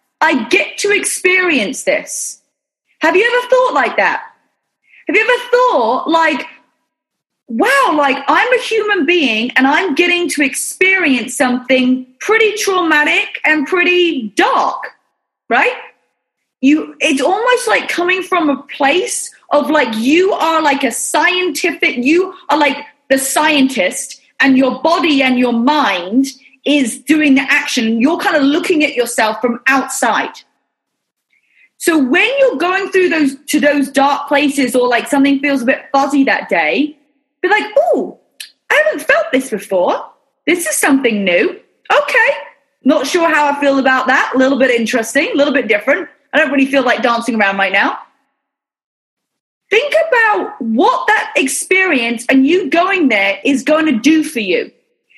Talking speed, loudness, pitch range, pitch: 155 wpm, -13 LUFS, 270-345 Hz, 290 Hz